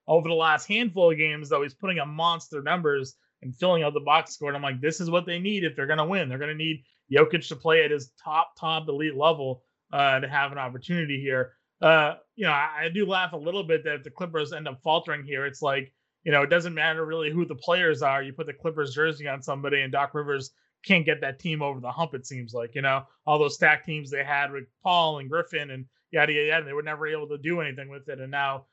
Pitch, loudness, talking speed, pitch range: 150 Hz, -26 LUFS, 265 wpm, 140-165 Hz